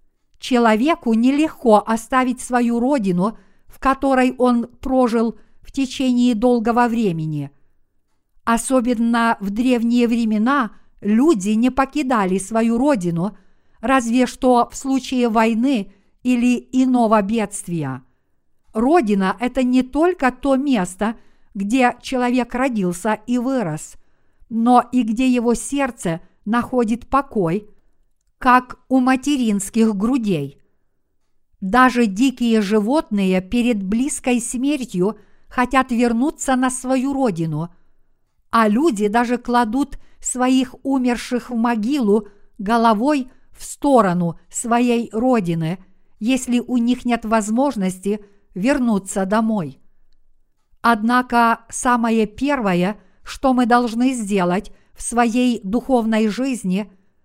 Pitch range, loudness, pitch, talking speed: 210-255 Hz, -19 LUFS, 240 Hz, 100 wpm